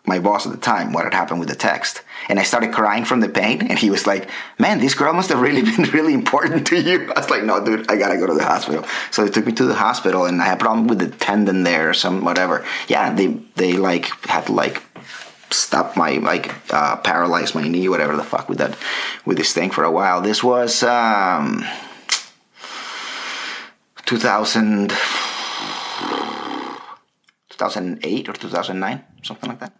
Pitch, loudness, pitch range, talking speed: 115 Hz, -18 LUFS, 95-125 Hz, 200 wpm